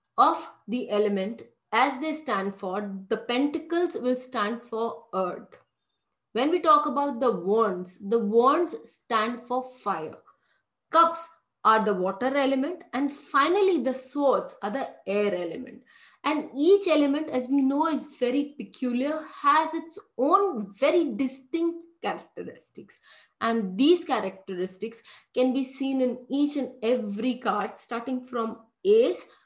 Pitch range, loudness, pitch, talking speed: 225-300 Hz, -26 LUFS, 255 Hz, 135 wpm